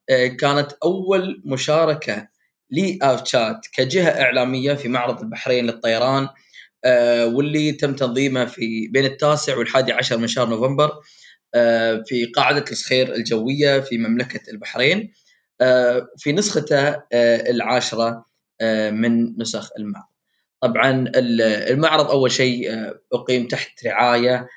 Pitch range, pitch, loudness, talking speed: 115-140 Hz, 125 Hz, -19 LUFS, 100 wpm